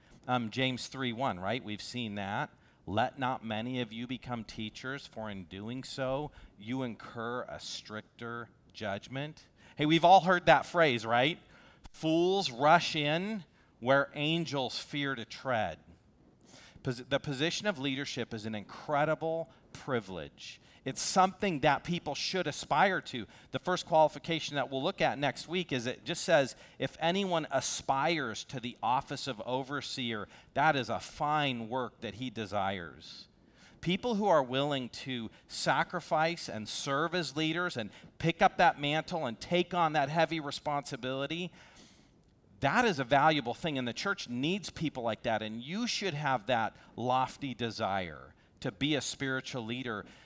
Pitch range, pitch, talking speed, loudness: 115-160 Hz, 135 Hz, 155 wpm, -32 LUFS